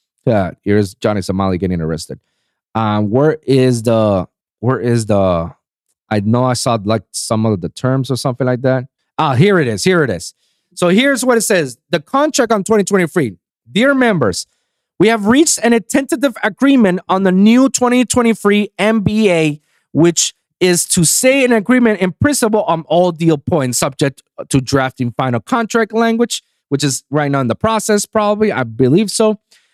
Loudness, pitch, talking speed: -14 LUFS, 170 Hz, 170 wpm